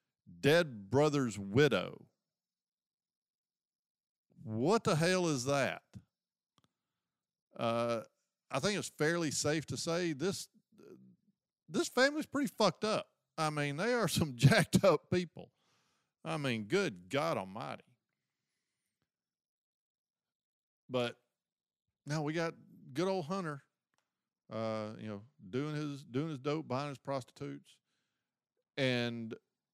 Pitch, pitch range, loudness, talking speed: 150 Hz, 125-180 Hz, -34 LUFS, 110 wpm